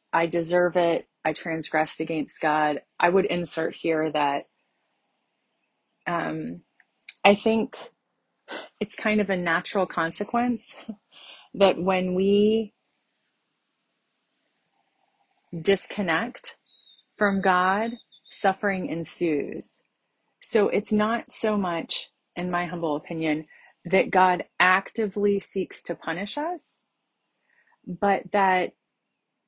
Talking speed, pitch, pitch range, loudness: 95 wpm, 185 Hz, 165-210 Hz, -25 LUFS